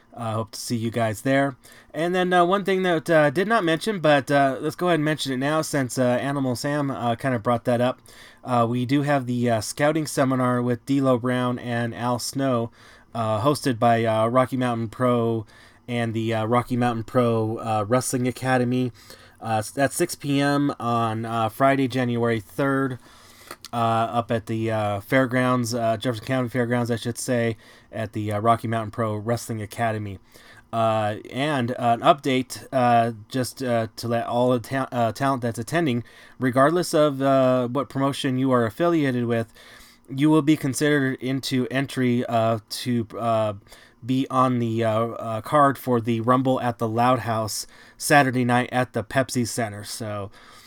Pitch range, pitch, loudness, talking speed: 115-135 Hz, 125 Hz, -23 LUFS, 180 wpm